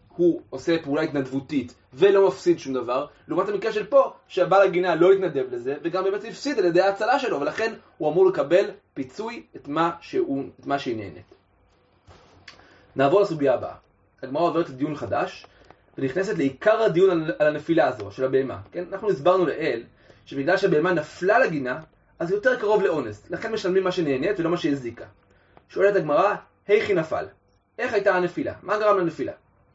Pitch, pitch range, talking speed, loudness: 175 Hz, 140-205 Hz, 160 wpm, -23 LUFS